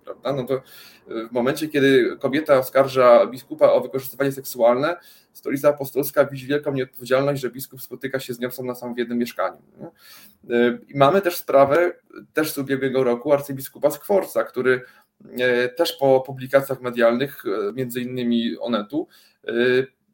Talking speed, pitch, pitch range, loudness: 125 wpm, 135 Hz, 125-140 Hz, -21 LUFS